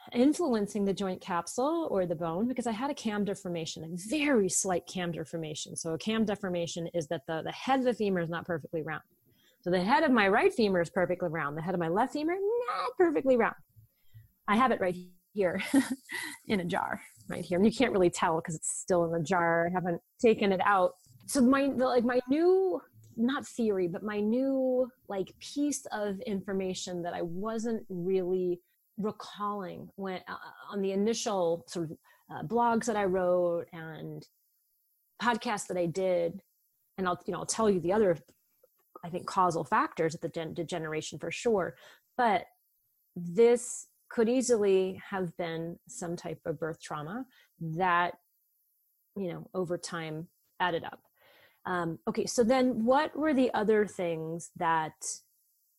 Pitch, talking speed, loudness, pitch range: 190 Hz, 175 wpm, -30 LUFS, 170-235 Hz